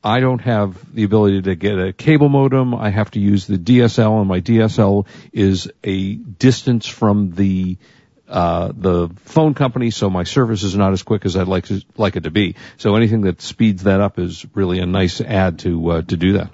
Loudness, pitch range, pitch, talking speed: -17 LUFS, 95-115 Hz, 100 Hz, 215 wpm